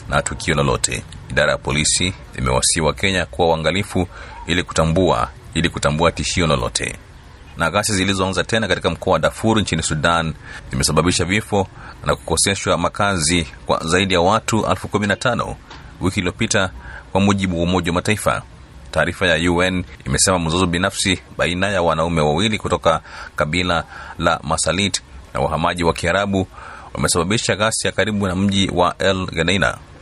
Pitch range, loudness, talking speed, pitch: 80-100 Hz, -18 LUFS, 140 wpm, 90 Hz